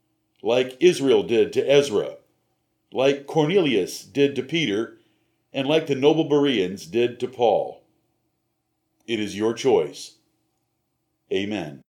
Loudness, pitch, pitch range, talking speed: -22 LUFS, 145 Hz, 130-165 Hz, 115 wpm